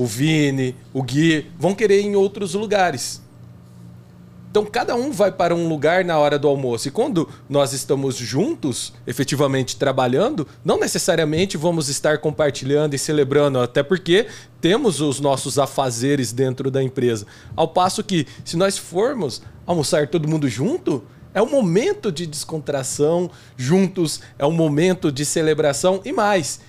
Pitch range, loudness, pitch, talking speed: 135-180 Hz, -20 LUFS, 150 Hz, 150 wpm